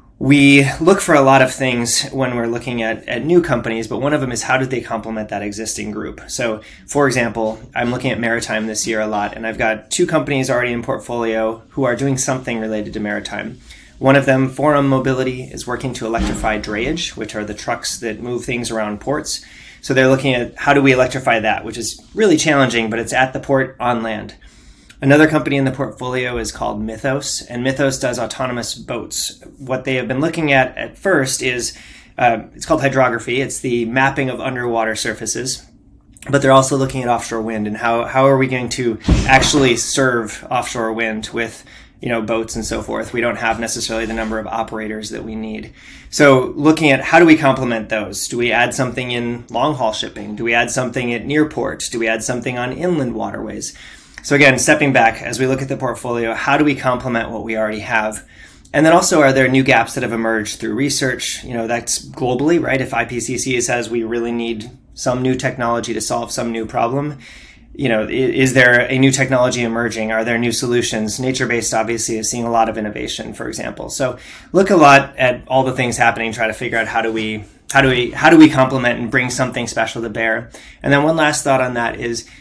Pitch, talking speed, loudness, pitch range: 120 Hz, 215 wpm, -16 LUFS, 115-135 Hz